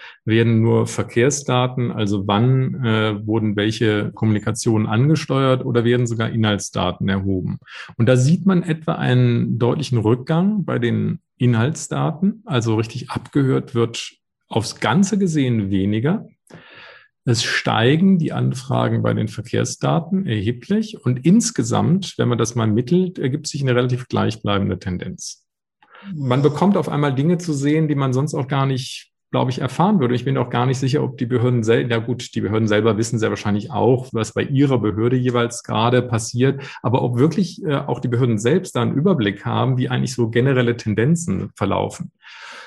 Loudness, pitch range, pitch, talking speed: -19 LUFS, 115-145 Hz, 125 Hz, 165 wpm